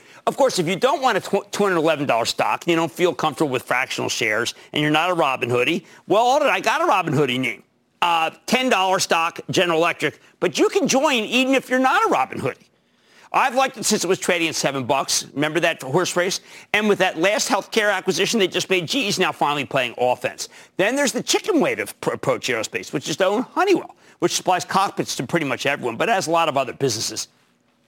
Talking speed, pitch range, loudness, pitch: 215 wpm, 155-215 Hz, -20 LUFS, 180 Hz